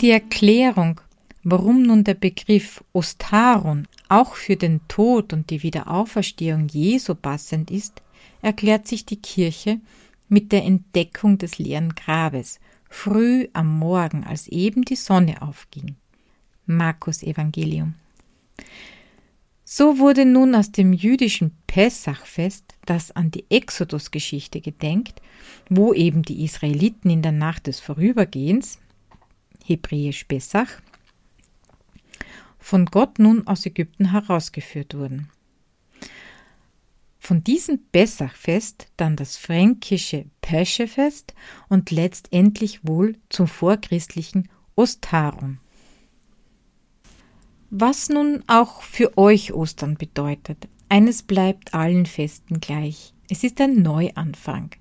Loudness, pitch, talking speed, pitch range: -20 LUFS, 185 Hz, 105 wpm, 160-215 Hz